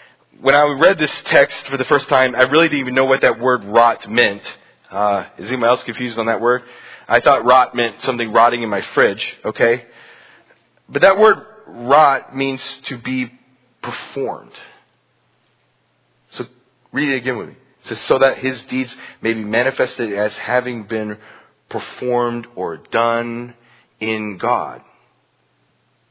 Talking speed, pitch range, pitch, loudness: 155 wpm, 115-130 Hz, 125 Hz, -17 LUFS